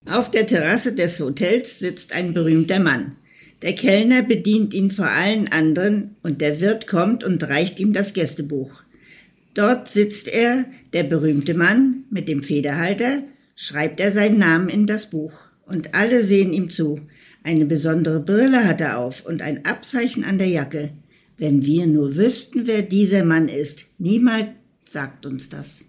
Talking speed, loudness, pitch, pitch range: 160 wpm, -19 LUFS, 185 Hz, 155-215 Hz